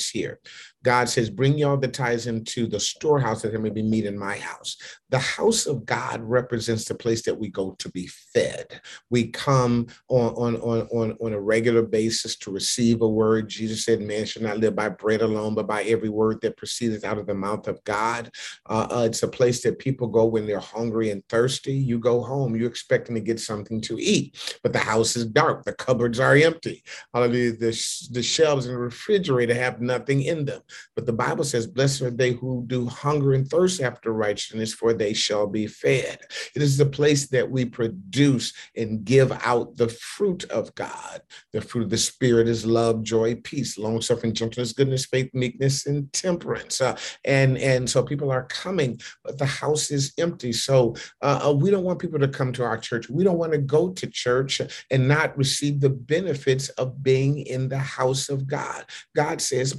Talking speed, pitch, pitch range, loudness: 205 wpm, 120 Hz, 115-135 Hz, -24 LUFS